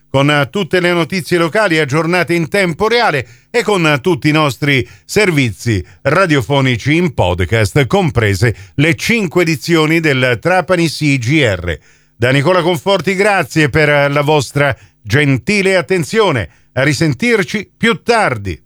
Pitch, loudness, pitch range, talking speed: 155 Hz, -13 LUFS, 135-185 Hz, 120 wpm